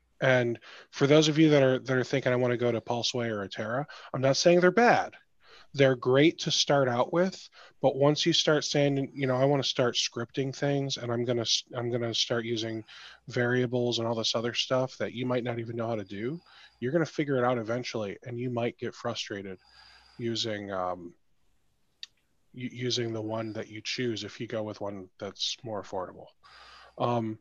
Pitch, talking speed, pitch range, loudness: 120 Hz, 210 wpm, 115-135 Hz, -28 LUFS